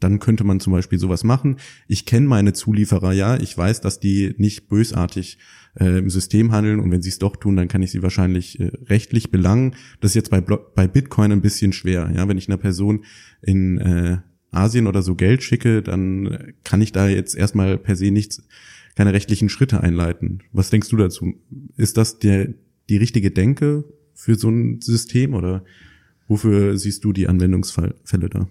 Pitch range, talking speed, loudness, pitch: 95-110 Hz, 190 wpm, -19 LUFS, 100 Hz